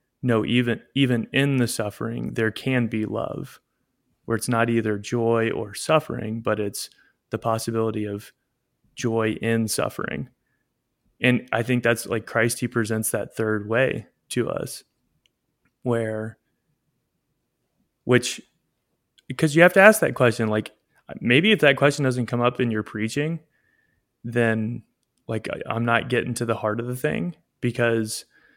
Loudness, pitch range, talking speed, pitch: -23 LUFS, 110-125 Hz, 145 wpm, 115 Hz